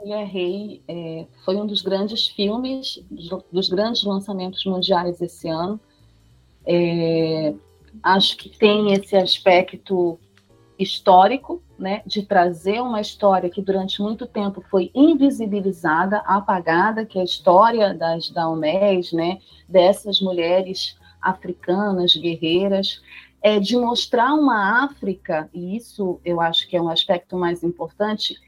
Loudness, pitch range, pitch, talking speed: -20 LUFS, 170-205 Hz, 190 Hz, 120 wpm